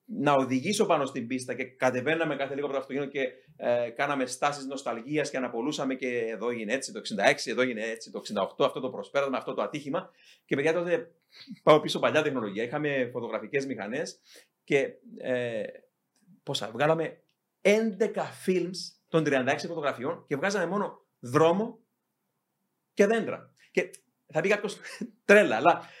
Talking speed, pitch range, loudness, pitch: 155 wpm, 130-180 Hz, -28 LUFS, 145 Hz